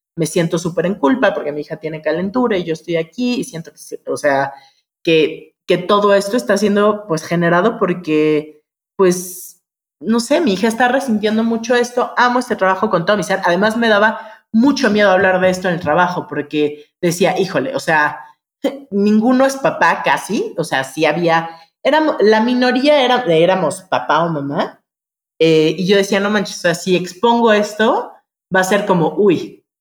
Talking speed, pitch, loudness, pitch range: 185 wpm, 190 Hz, -15 LUFS, 165-225 Hz